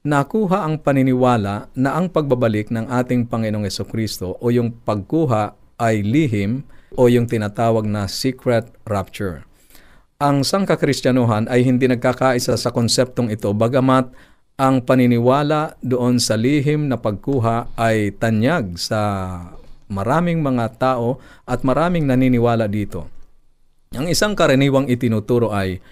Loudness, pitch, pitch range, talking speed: -18 LUFS, 125 Hz, 110-135 Hz, 120 wpm